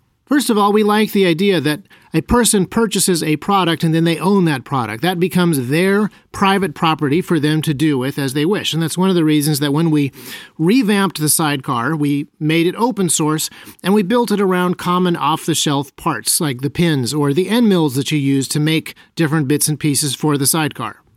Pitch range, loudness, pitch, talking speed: 150-190 Hz, -16 LUFS, 160 Hz, 215 wpm